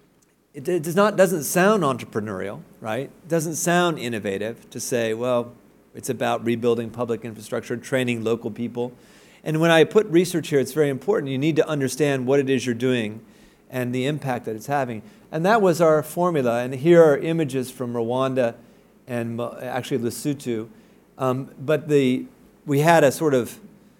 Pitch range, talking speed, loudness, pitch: 120-160 Hz, 170 wpm, -22 LUFS, 130 Hz